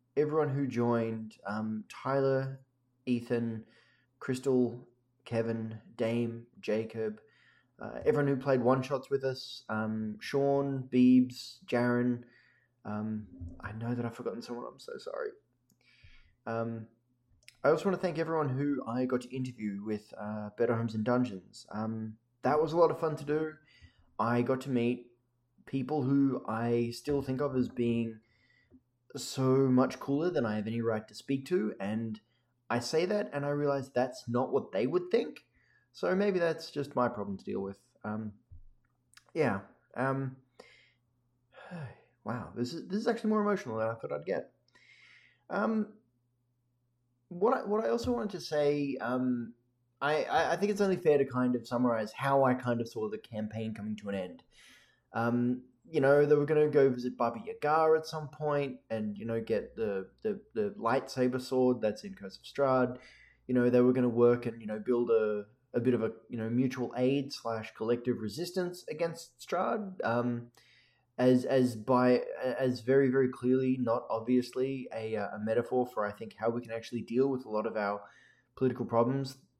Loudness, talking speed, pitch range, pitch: -32 LUFS, 175 wpm, 115-135 Hz, 125 Hz